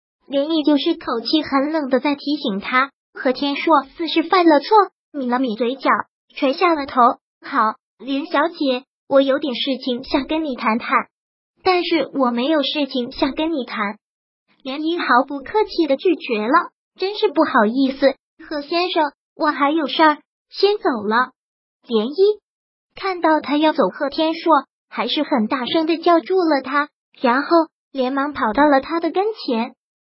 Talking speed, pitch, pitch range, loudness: 225 characters per minute, 290 Hz, 260-325 Hz, -19 LUFS